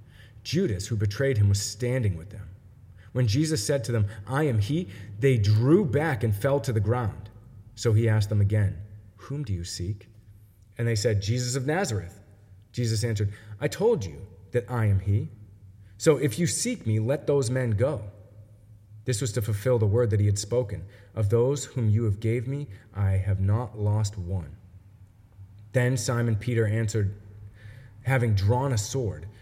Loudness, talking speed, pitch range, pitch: -26 LUFS, 175 wpm, 100-125 Hz, 110 Hz